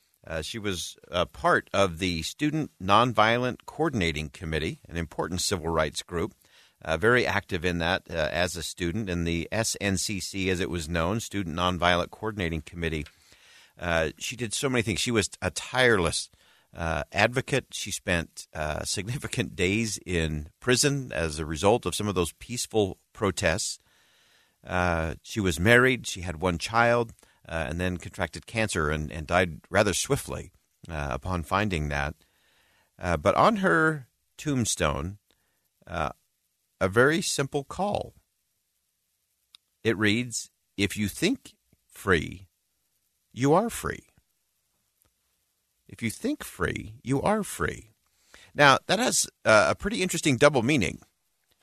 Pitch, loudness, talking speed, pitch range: 95 Hz, -27 LUFS, 140 wpm, 85-115 Hz